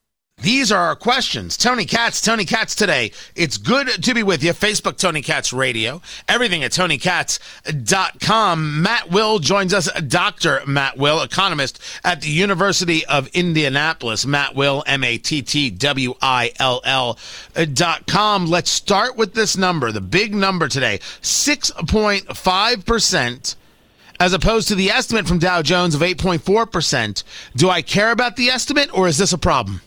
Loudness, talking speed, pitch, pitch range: -17 LUFS, 145 wpm, 175 Hz, 140-205 Hz